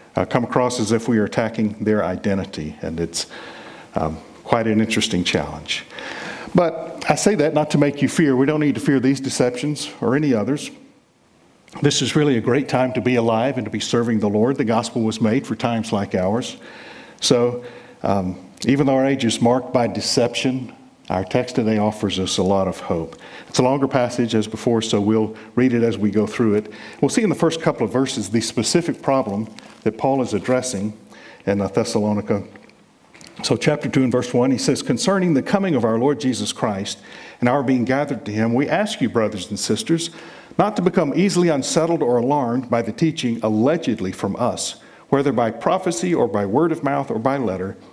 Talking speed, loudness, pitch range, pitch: 205 wpm, -20 LUFS, 110-140 Hz, 120 Hz